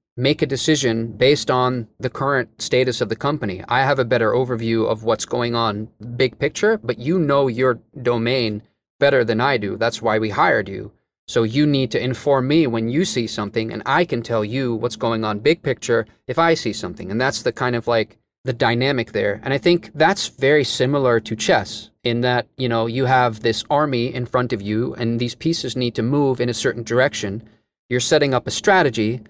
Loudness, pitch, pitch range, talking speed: -19 LUFS, 125 Hz, 115-135 Hz, 215 wpm